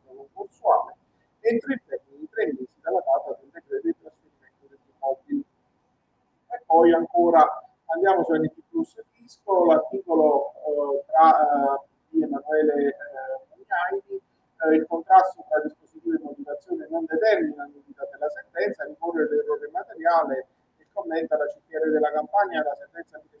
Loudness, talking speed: -24 LUFS, 135 wpm